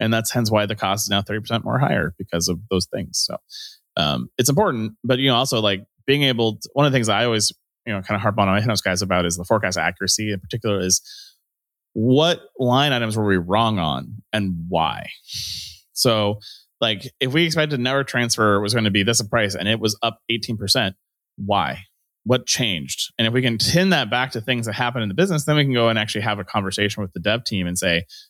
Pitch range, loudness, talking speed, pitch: 100-120 Hz, -20 LUFS, 230 wpm, 110 Hz